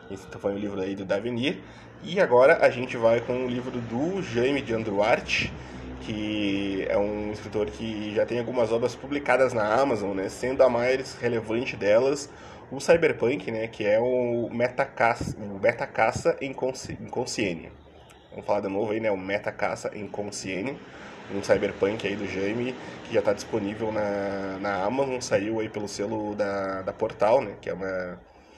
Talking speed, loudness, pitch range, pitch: 175 wpm, -26 LUFS, 100-125 Hz, 110 Hz